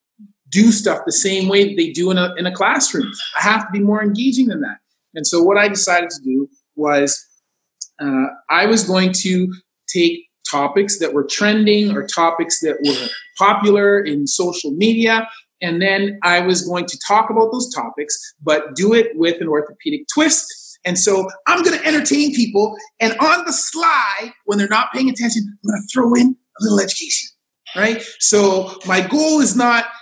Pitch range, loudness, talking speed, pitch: 180-240 Hz, -16 LUFS, 190 wpm, 205 Hz